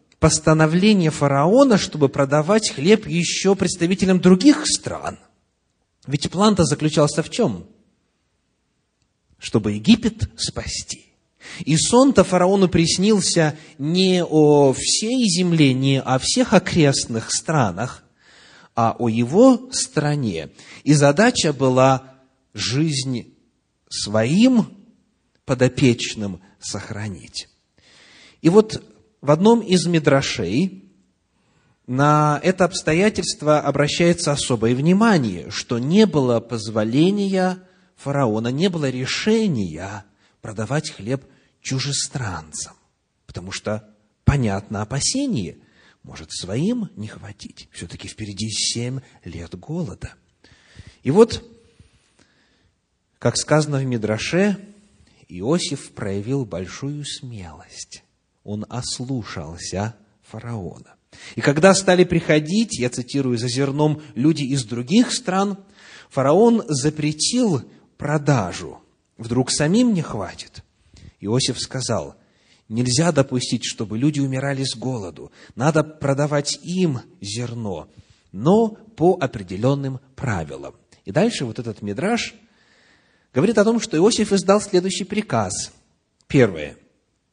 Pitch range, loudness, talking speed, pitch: 115-180 Hz, -19 LUFS, 95 wpm, 140 Hz